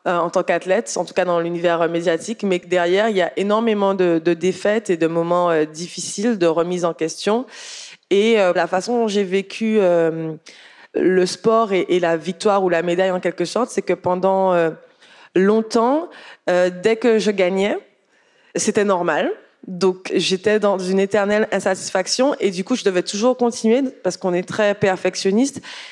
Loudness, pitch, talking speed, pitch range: -19 LUFS, 190 Hz, 175 wpm, 175-220 Hz